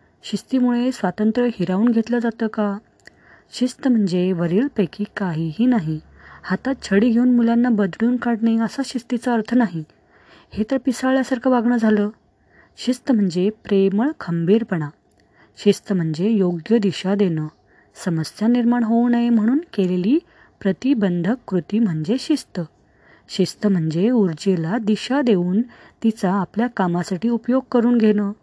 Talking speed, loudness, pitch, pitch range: 120 wpm, -20 LUFS, 215 Hz, 185-240 Hz